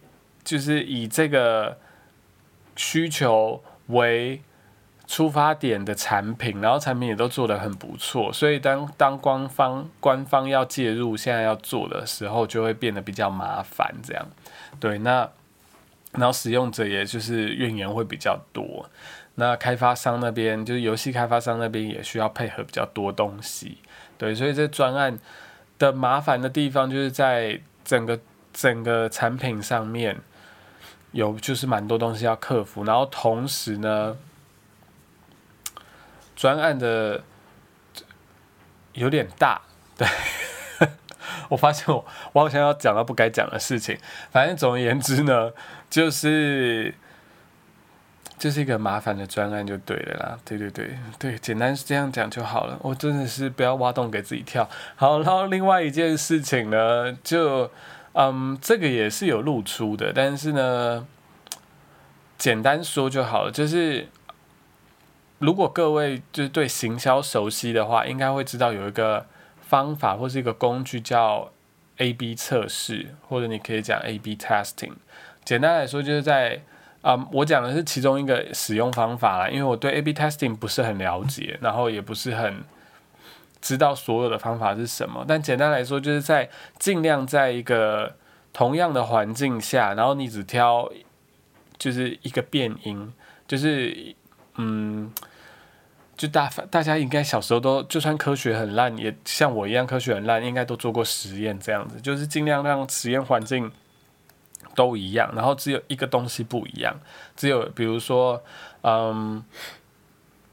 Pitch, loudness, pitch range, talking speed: 125 Hz, -24 LUFS, 115-140 Hz, 235 characters per minute